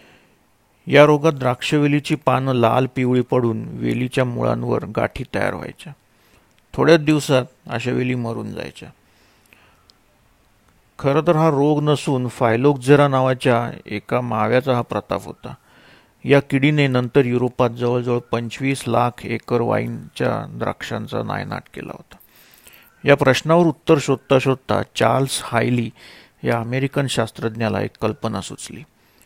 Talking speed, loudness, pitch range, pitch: 115 wpm, -19 LUFS, 115-140 Hz, 125 Hz